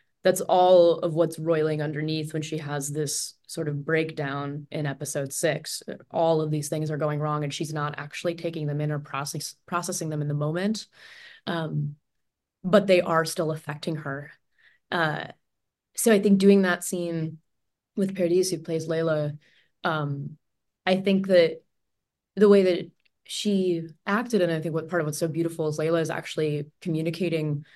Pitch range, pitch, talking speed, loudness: 150-175 Hz, 160 Hz, 170 wpm, -26 LUFS